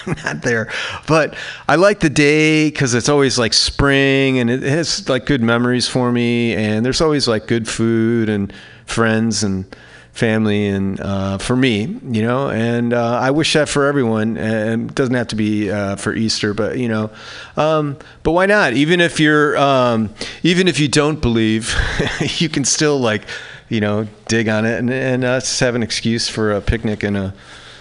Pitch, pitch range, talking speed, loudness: 120 Hz, 110-140 Hz, 190 wpm, -16 LUFS